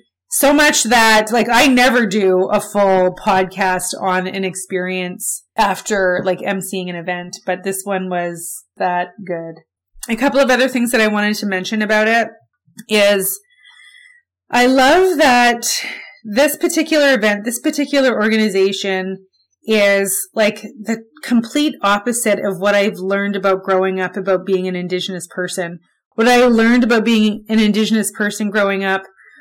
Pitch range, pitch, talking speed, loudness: 190-240 Hz, 210 Hz, 150 wpm, -15 LUFS